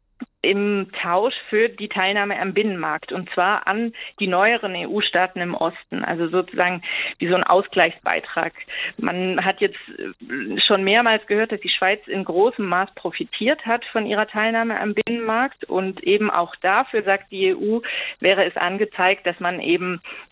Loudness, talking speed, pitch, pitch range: -21 LUFS, 155 wpm, 200 Hz, 185-220 Hz